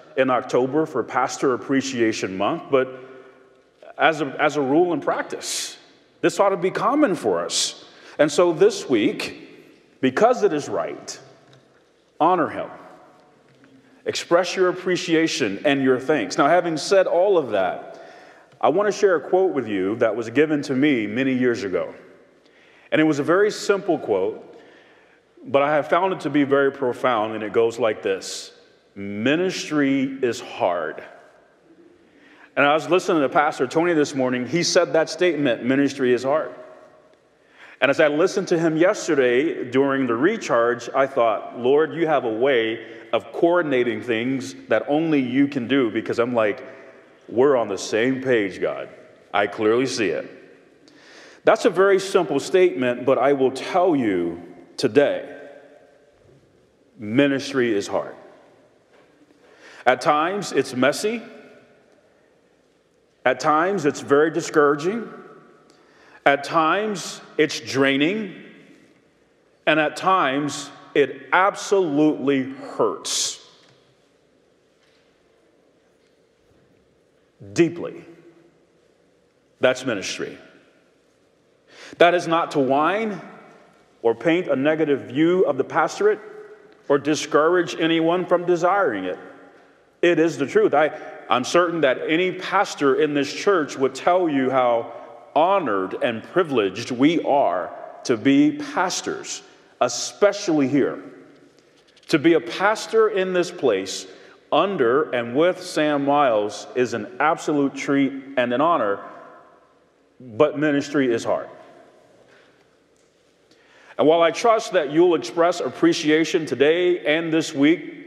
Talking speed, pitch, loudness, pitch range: 130 wpm, 160 Hz, -21 LUFS, 135-205 Hz